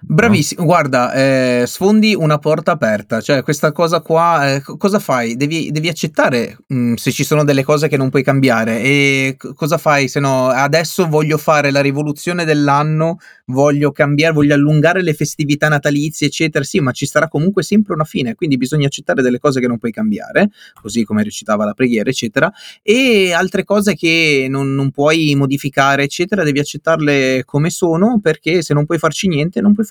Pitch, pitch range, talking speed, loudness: 150 Hz, 135-170 Hz, 185 wpm, -14 LUFS